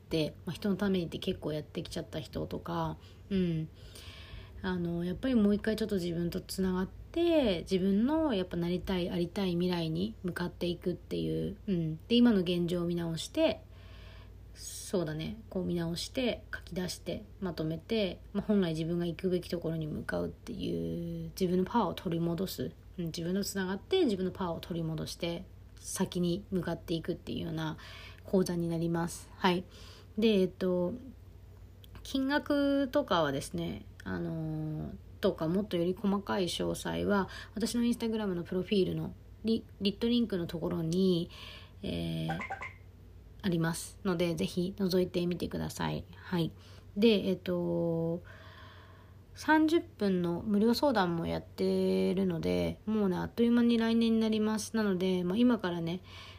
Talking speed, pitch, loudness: 320 characters per minute, 175 Hz, -33 LUFS